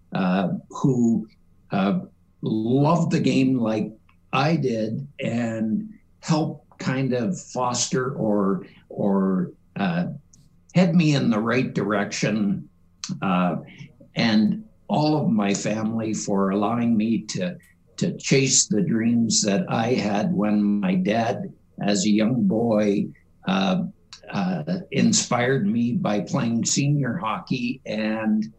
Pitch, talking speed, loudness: 130 Hz, 120 wpm, -23 LUFS